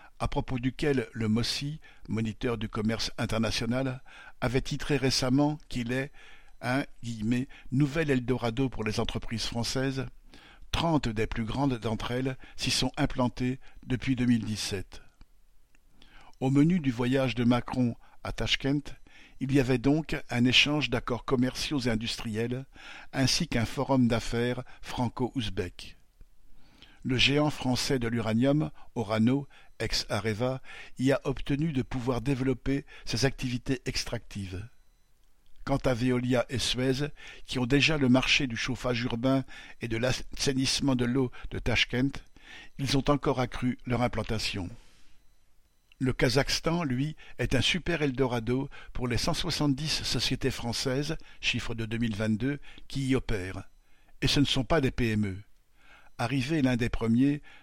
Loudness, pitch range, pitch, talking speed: -29 LUFS, 115-135 Hz, 125 Hz, 135 wpm